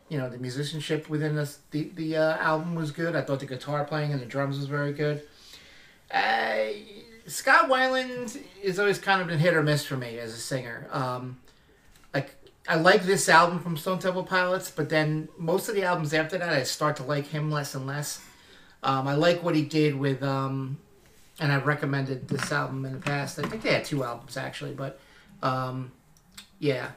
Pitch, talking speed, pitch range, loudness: 150 Hz, 205 wpm, 135-170 Hz, -27 LUFS